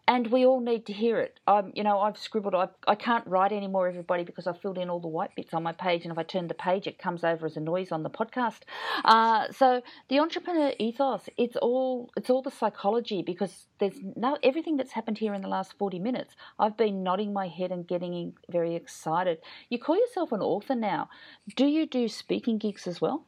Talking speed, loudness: 225 wpm, -28 LUFS